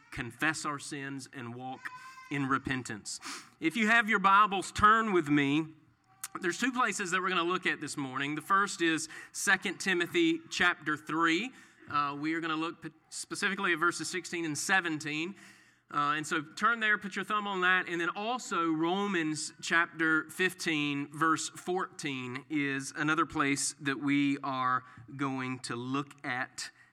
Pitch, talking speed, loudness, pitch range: 160 Hz, 165 wpm, -30 LUFS, 145-185 Hz